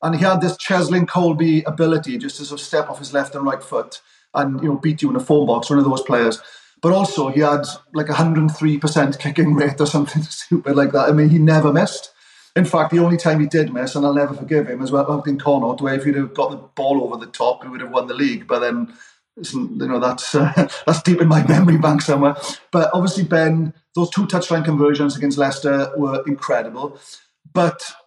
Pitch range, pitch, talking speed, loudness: 145-170 Hz, 155 Hz, 235 wpm, -18 LUFS